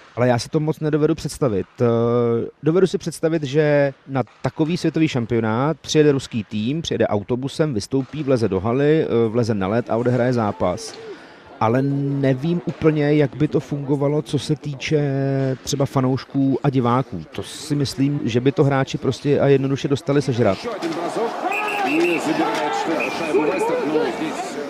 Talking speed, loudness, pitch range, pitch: 135 wpm, -20 LUFS, 120-150 Hz, 140 Hz